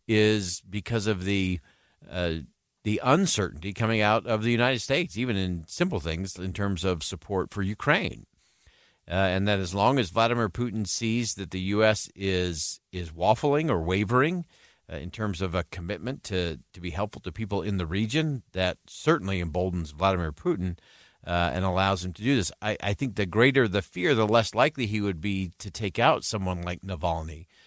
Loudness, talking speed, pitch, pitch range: -27 LUFS, 185 wpm, 100 Hz, 90-110 Hz